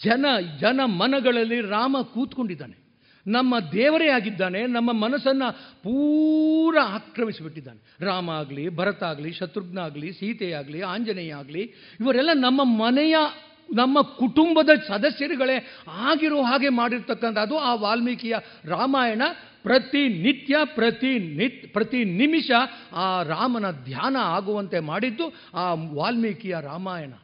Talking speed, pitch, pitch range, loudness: 100 wpm, 235 Hz, 190-265 Hz, -23 LUFS